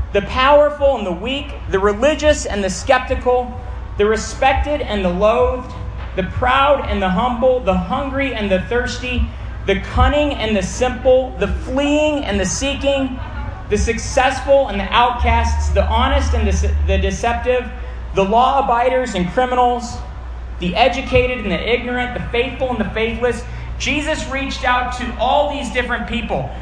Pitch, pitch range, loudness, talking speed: 245 Hz, 200-265 Hz, -17 LUFS, 155 wpm